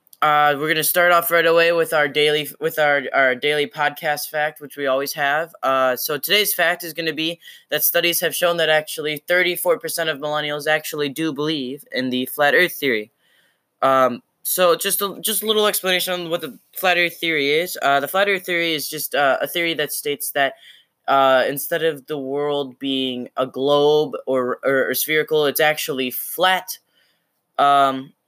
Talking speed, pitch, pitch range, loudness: 190 wpm, 150 Hz, 140-170 Hz, -19 LUFS